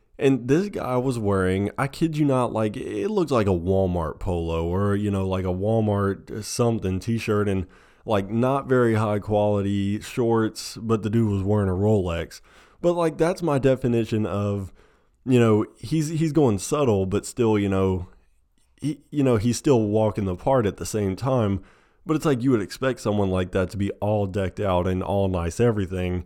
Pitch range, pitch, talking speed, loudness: 95-125 Hz, 105 Hz, 190 wpm, -23 LUFS